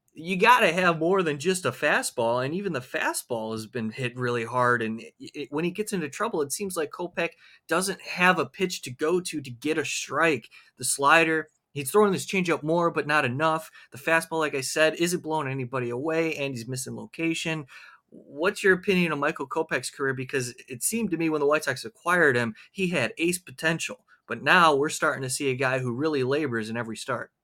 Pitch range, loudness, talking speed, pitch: 130-170 Hz, -25 LUFS, 215 wpm, 155 Hz